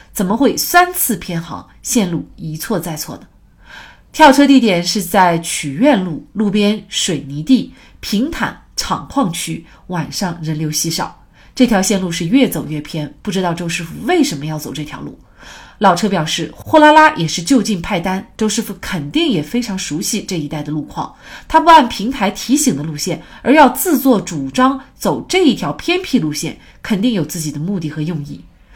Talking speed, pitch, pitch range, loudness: 265 characters per minute, 190 Hz, 160-245 Hz, -15 LUFS